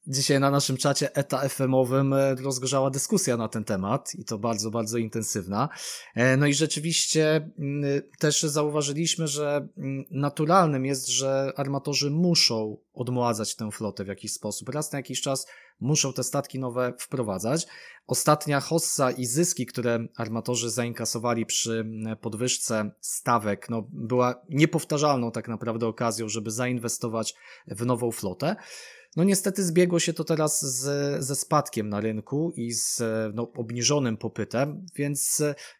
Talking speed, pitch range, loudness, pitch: 135 wpm, 115-145 Hz, -26 LUFS, 130 Hz